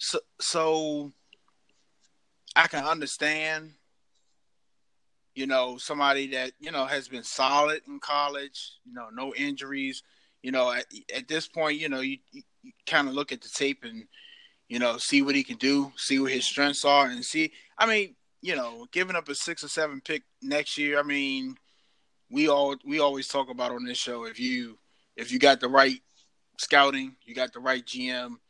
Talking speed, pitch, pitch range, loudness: 185 wpm, 140 Hz, 130-155 Hz, -27 LUFS